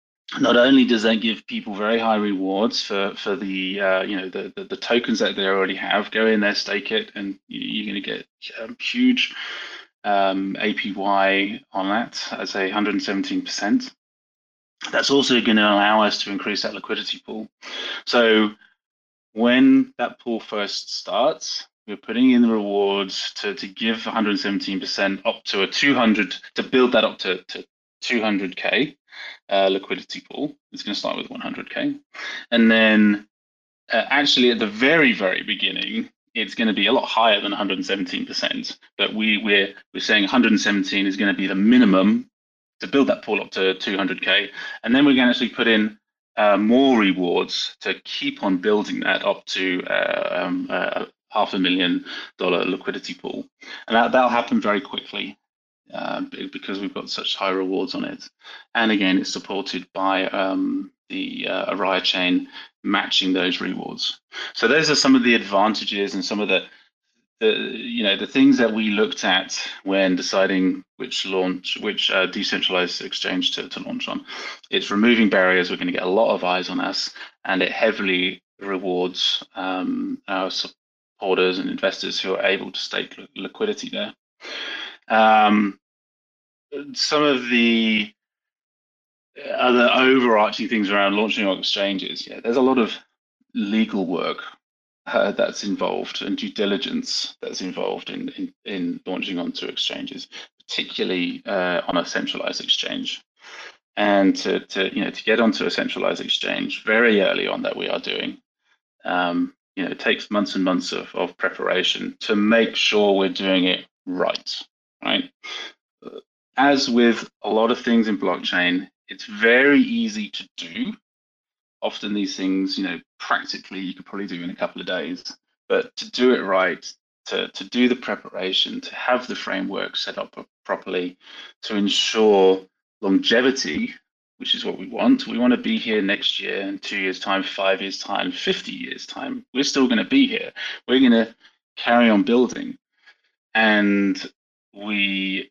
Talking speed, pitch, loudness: 165 wpm, 120 Hz, -21 LUFS